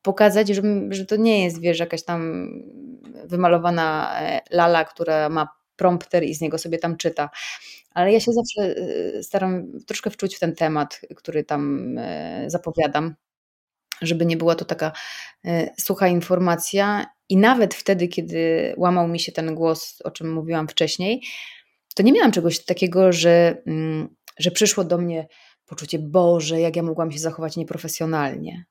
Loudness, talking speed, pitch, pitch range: -21 LUFS, 150 wpm, 170 Hz, 160-195 Hz